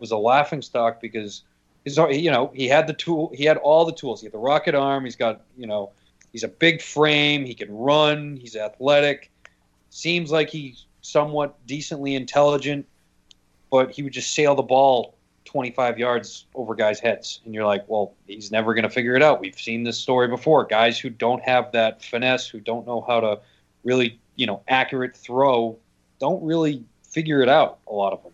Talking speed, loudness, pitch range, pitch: 195 wpm, -21 LUFS, 115-145 Hz, 125 Hz